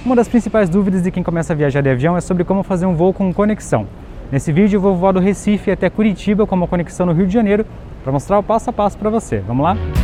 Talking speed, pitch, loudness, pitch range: 270 wpm, 190 Hz, -16 LUFS, 175-210 Hz